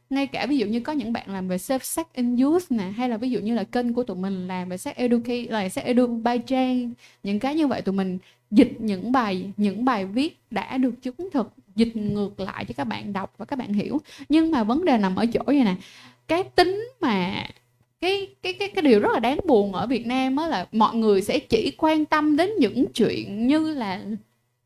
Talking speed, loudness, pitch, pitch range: 240 wpm, -24 LUFS, 245 Hz, 205-280 Hz